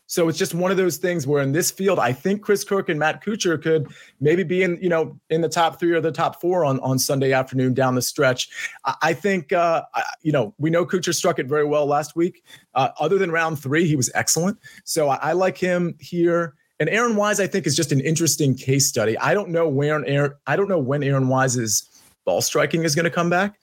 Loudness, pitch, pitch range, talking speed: -21 LUFS, 165 Hz, 145-180 Hz, 250 wpm